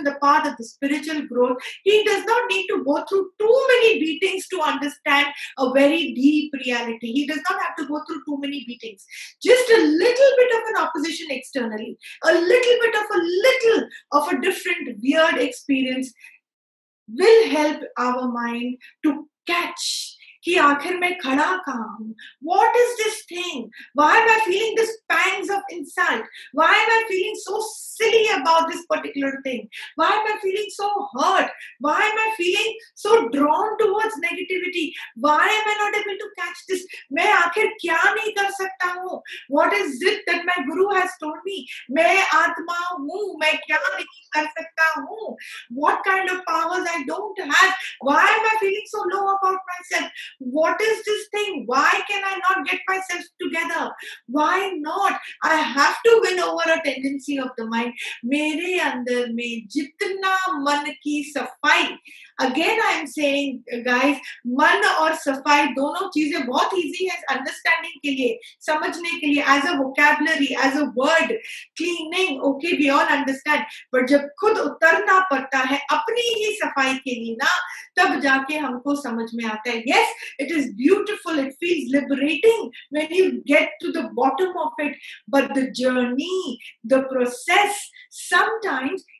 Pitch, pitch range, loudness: 330 Hz, 280-390 Hz, -20 LUFS